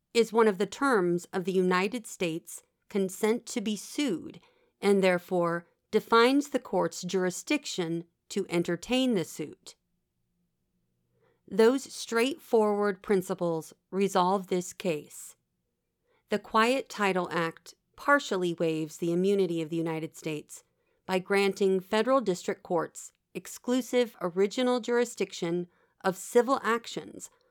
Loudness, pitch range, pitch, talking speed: -29 LUFS, 175-235 Hz, 195 Hz, 115 wpm